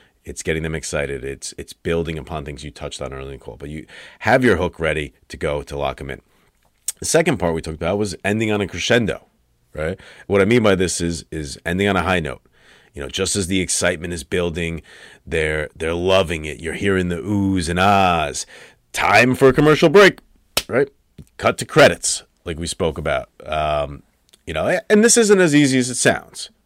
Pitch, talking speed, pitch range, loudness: 85 Hz, 210 wpm, 80-100 Hz, -18 LUFS